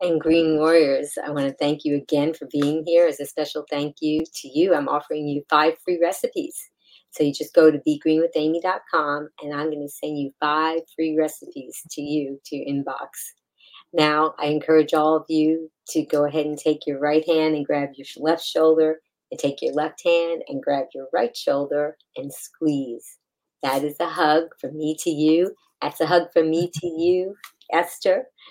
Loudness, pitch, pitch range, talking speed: -22 LUFS, 155 Hz, 150-165 Hz, 195 wpm